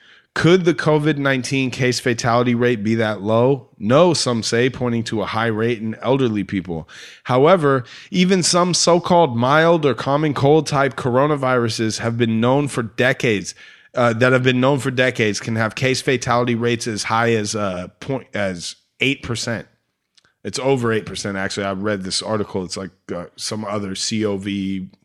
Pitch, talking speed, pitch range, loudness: 120 Hz, 175 wpm, 110-135 Hz, -18 LUFS